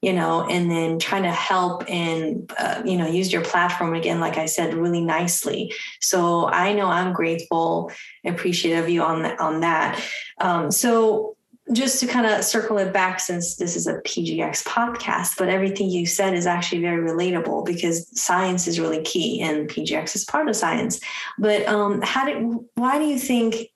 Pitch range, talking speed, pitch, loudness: 170-215 Hz, 185 wpm, 180 Hz, -22 LUFS